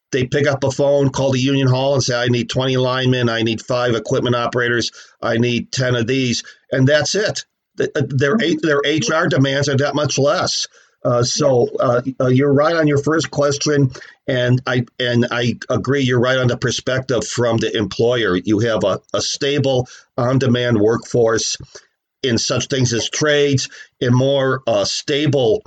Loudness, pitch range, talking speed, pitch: -17 LUFS, 120-140 Hz, 175 wpm, 130 Hz